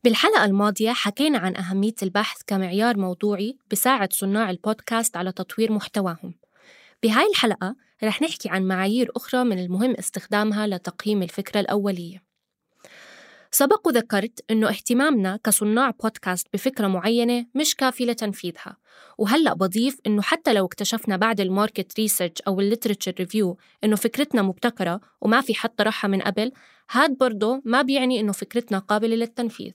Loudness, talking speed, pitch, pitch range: -23 LUFS, 135 wpm, 215 Hz, 195-240 Hz